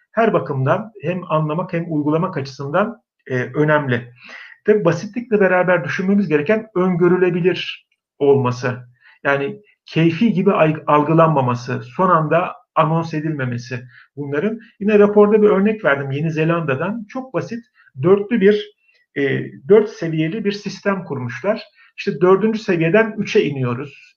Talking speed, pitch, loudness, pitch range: 110 wpm, 175 Hz, -18 LUFS, 145-210 Hz